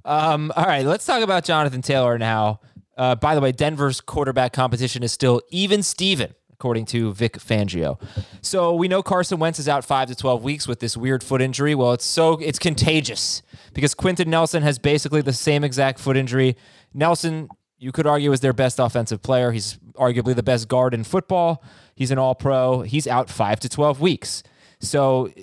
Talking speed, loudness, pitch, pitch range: 190 wpm, -20 LUFS, 130 Hz, 125-150 Hz